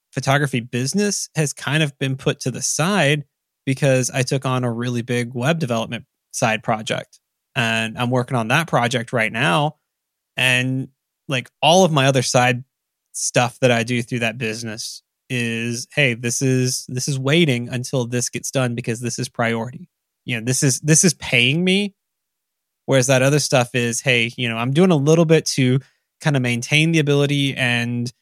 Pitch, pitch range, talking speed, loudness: 130 Hz, 120-145 Hz, 185 wpm, -19 LUFS